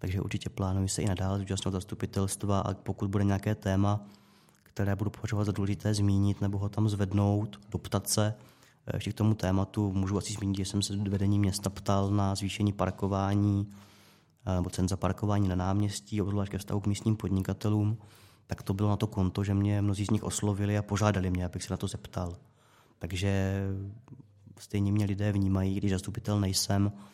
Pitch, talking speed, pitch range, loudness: 100 Hz, 180 wpm, 95-105 Hz, -31 LUFS